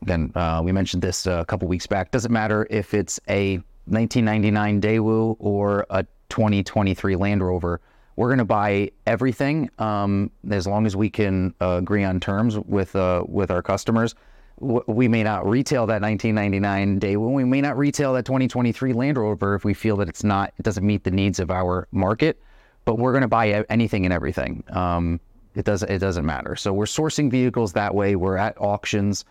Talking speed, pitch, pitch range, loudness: 190 wpm, 105 Hz, 95-110 Hz, -22 LUFS